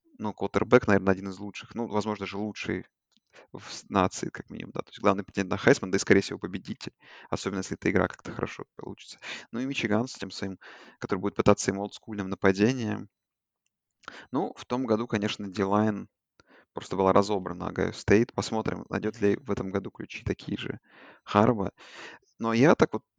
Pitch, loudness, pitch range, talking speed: 105 Hz, -28 LUFS, 100-110 Hz, 180 wpm